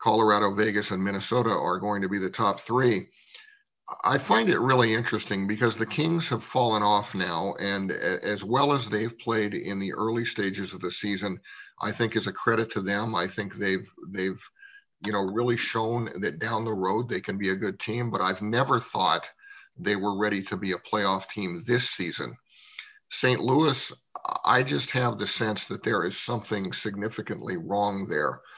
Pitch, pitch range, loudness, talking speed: 105 Hz, 100-120 Hz, -27 LUFS, 185 wpm